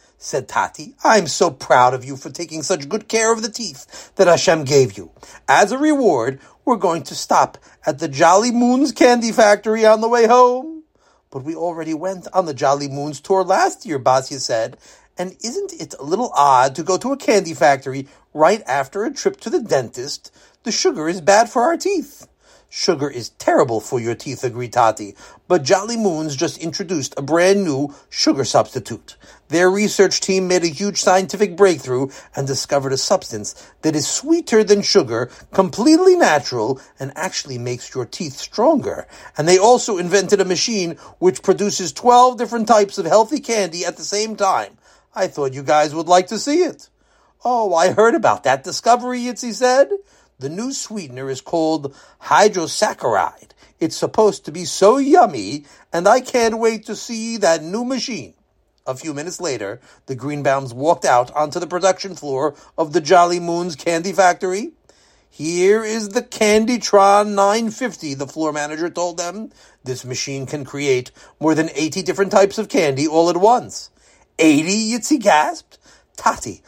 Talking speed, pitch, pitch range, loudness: 170 wpm, 185 Hz, 145-220 Hz, -17 LUFS